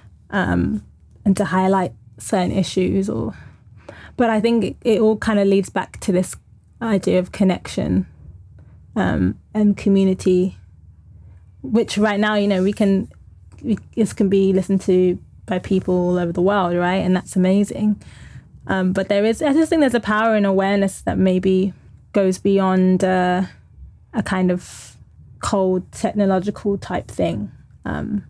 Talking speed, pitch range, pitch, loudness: 155 wpm, 180-205 Hz, 190 Hz, -19 LUFS